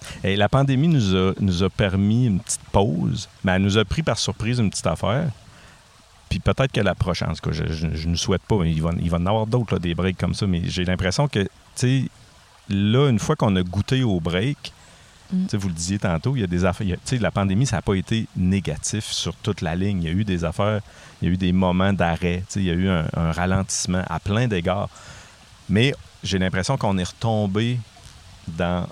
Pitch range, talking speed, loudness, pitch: 90-110 Hz, 230 wpm, -22 LUFS, 100 Hz